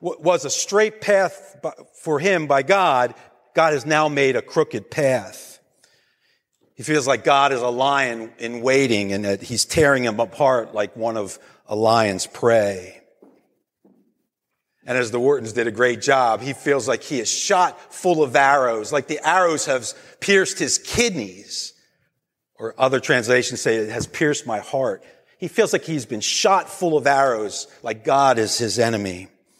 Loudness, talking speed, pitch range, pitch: -20 LUFS, 170 wpm, 115-160 Hz, 135 Hz